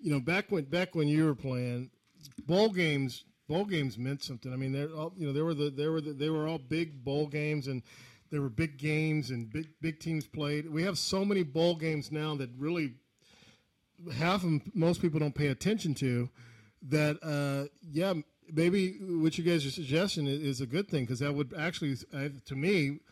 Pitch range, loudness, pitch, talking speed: 140-165 Hz, -32 LUFS, 150 Hz, 205 wpm